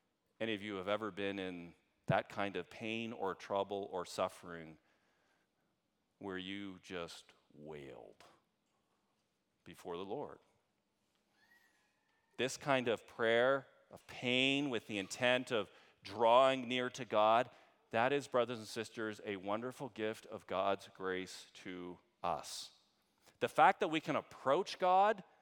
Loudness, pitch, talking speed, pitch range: -37 LUFS, 105 Hz, 130 wpm, 95-125 Hz